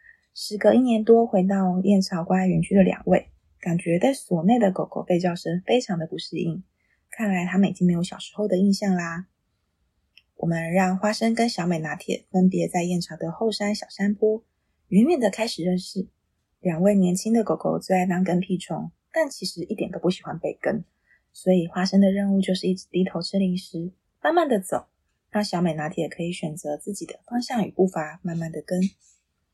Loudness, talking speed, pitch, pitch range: -24 LUFS, 285 characters per minute, 185 Hz, 170-205 Hz